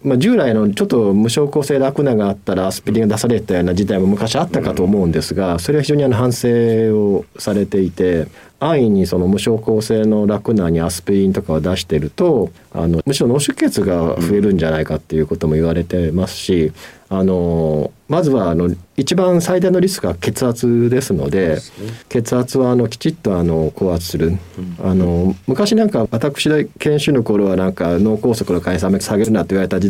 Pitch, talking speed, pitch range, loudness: 100 Hz, 395 characters per minute, 90-125 Hz, -16 LUFS